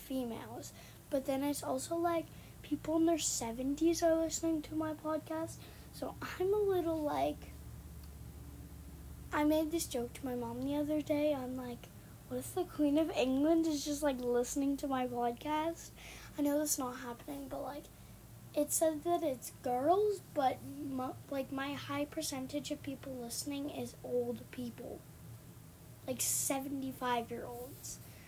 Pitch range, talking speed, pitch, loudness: 250-310 Hz, 155 wpm, 280 Hz, -36 LUFS